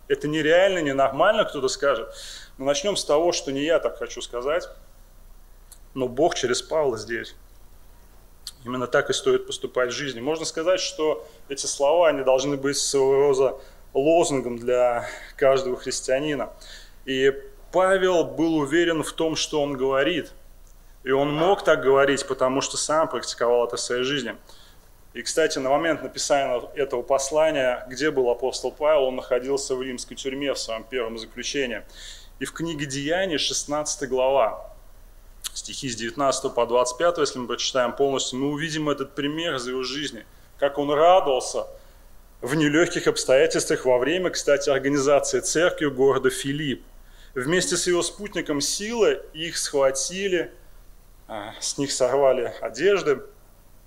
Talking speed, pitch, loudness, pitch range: 145 wpm, 140 Hz, -23 LUFS, 125-160 Hz